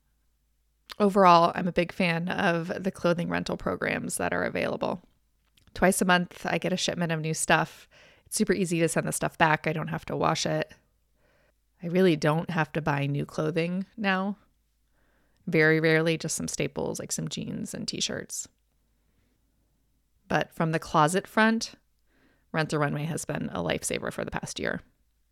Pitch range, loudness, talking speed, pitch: 155-185 Hz, -27 LUFS, 170 wpm, 165 Hz